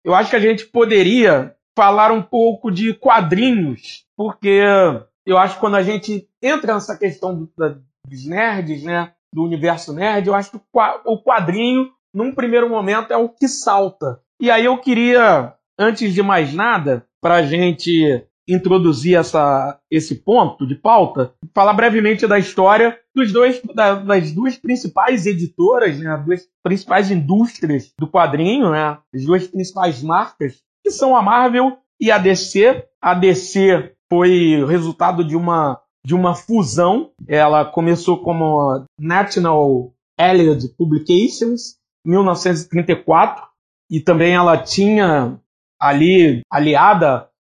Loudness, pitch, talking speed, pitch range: -15 LUFS, 185 Hz, 140 wpm, 160-220 Hz